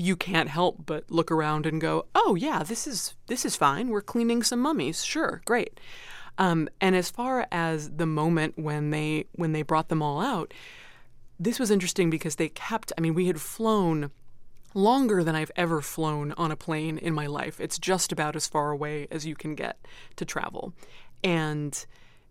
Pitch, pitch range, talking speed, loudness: 165 Hz, 155-195 Hz, 190 wpm, -27 LUFS